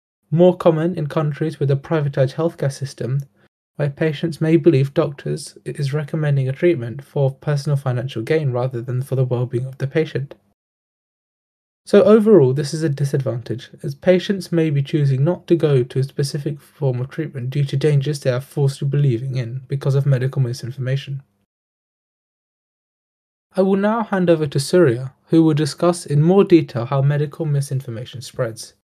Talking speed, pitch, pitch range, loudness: 165 wpm, 145 Hz, 130-160 Hz, -19 LUFS